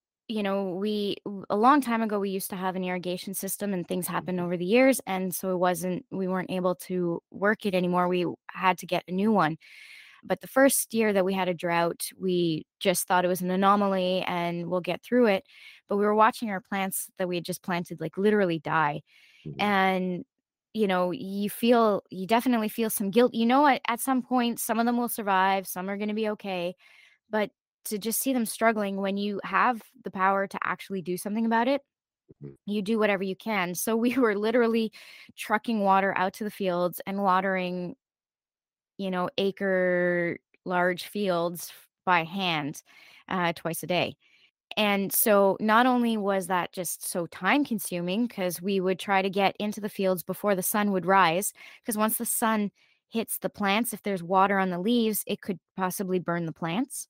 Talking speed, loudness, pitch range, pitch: 195 wpm, -27 LUFS, 180-220 Hz, 195 Hz